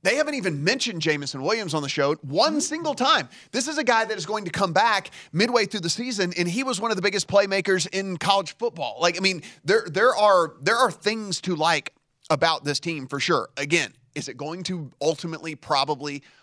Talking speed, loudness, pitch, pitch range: 220 wpm, -23 LUFS, 185 Hz, 155-215 Hz